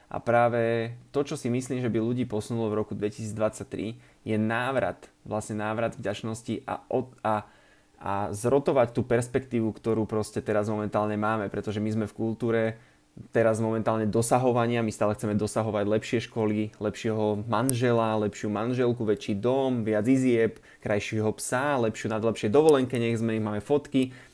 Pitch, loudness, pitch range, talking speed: 110 Hz, -27 LUFS, 105-120 Hz, 155 wpm